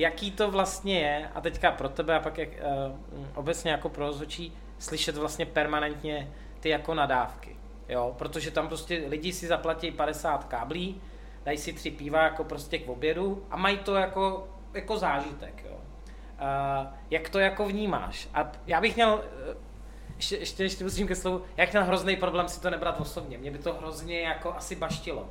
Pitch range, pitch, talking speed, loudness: 150-185 Hz, 165 Hz, 180 wpm, -30 LUFS